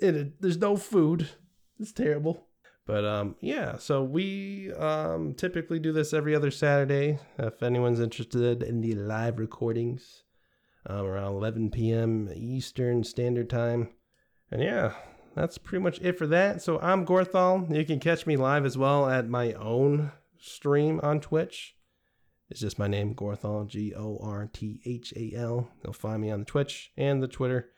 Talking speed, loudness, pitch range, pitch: 155 wpm, -29 LUFS, 115-160 Hz, 130 Hz